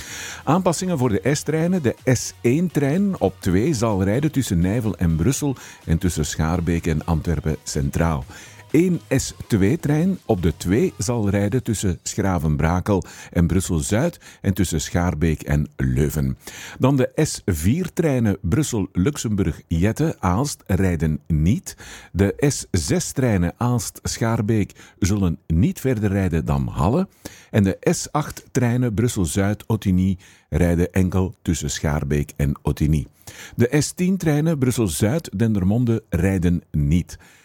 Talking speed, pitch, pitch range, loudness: 110 wpm, 100 Hz, 85-125 Hz, -21 LUFS